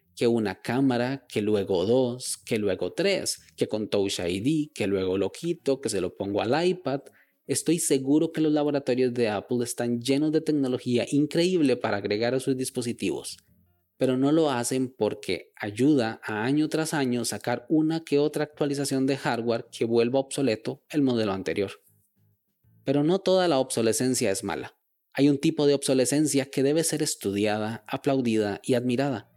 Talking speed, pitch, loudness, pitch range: 170 wpm, 130 Hz, -26 LUFS, 115-145 Hz